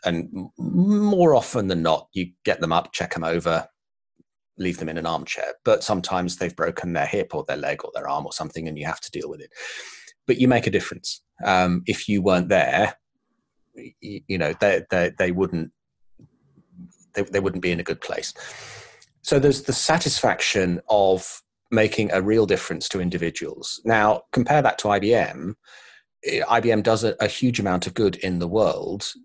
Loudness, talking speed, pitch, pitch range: -22 LUFS, 185 wpm, 95 Hz, 90-120 Hz